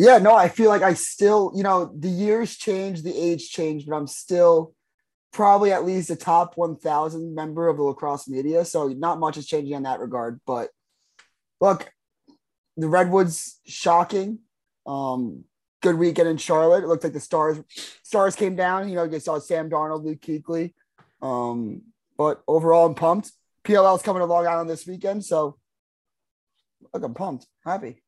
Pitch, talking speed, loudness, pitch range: 170 Hz, 175 wpm, -22 LUFS, 155-190 Hz